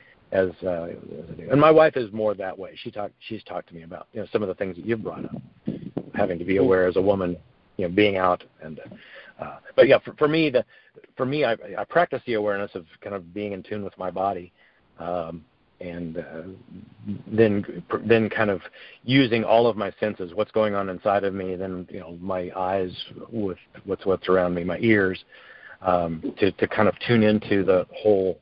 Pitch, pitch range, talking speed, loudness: 100 Hz, 90-110 Hz, 220 wpm, -23 LUFS